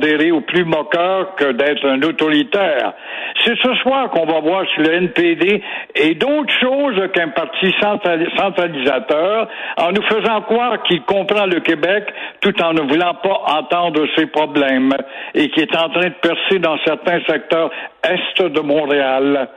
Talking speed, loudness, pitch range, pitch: 155 wpm, -16 LUFS, 155-205 Hz, 175 Hz